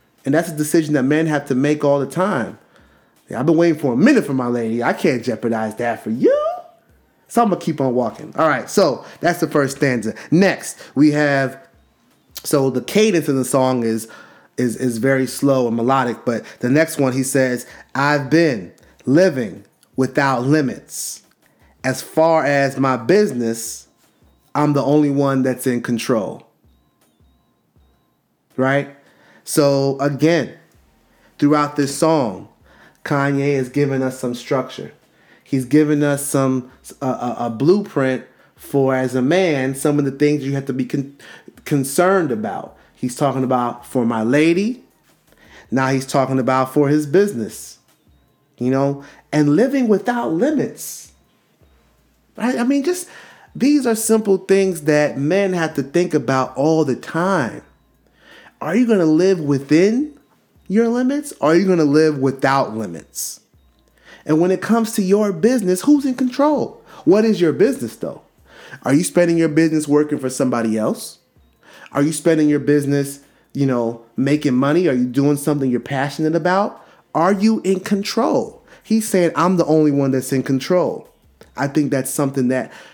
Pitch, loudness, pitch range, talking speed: 145 Hz, -18 LUFS, 130-170 Hz, 165 wpm